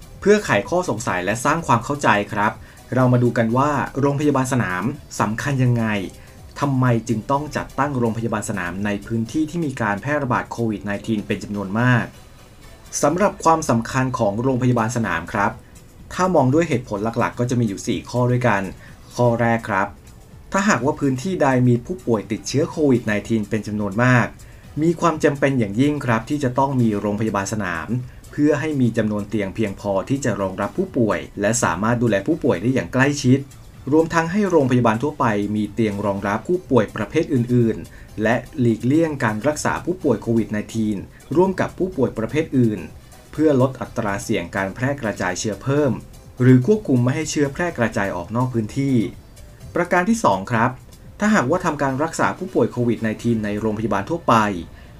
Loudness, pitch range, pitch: -20 LUFS, 110-140 Hz, 120 Hz